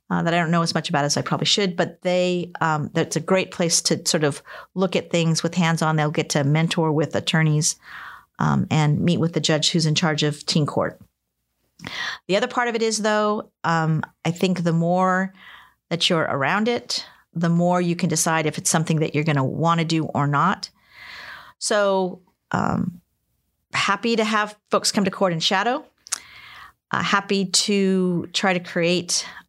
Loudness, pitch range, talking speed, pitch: -21 LUFS, 160-190 Hz, 195 wpm, 170 Hz